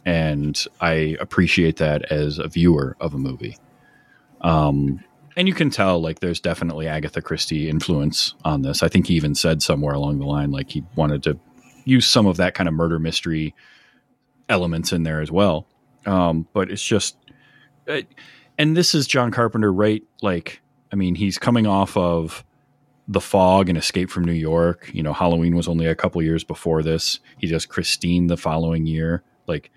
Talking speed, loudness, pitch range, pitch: 185 wpm, -20 LUFS, 80-95 Hz, 85 Hz